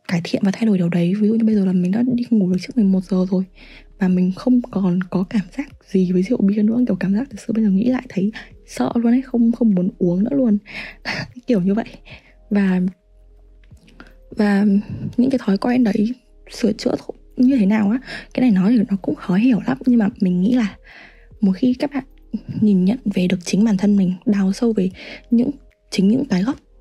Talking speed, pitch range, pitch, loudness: 230 wpm, 190-240 Hz, 210 Hz, -19 LUFS